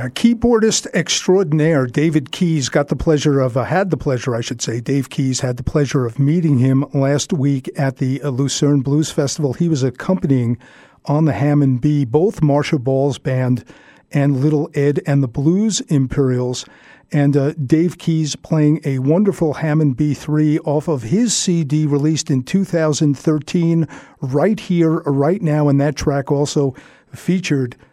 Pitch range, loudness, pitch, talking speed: 140-160 Hz, -17 LUFS, 150 Hz, 160 wpm